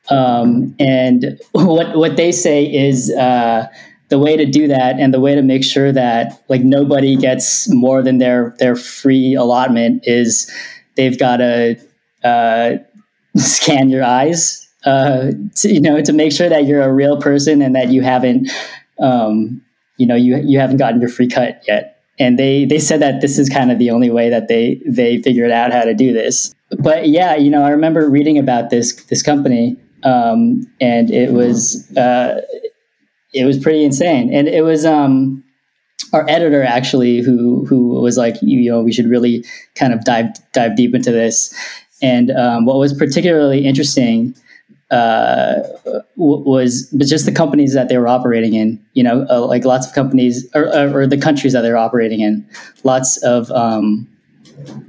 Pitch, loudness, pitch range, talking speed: 130 Hz, -13 LUFS, 120-145 Hz, 180 wpm